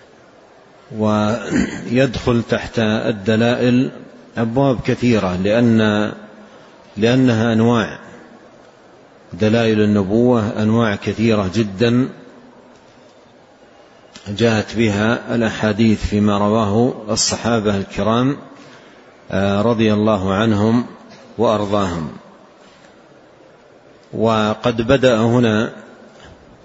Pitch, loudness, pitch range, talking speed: 110 Hz, -17 LUFS, 105-120 Hz, 60 wpm